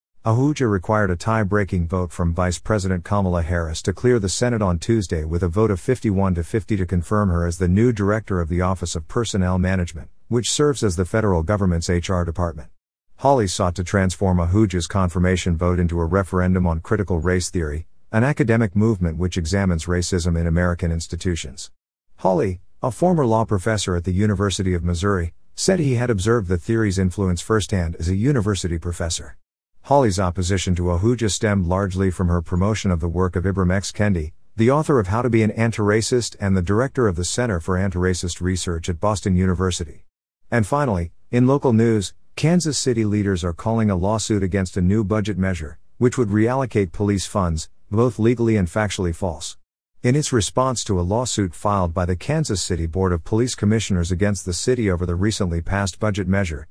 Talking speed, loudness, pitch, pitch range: 185 wpm, -21 LUFS, 95 Hz, 90-110 Hz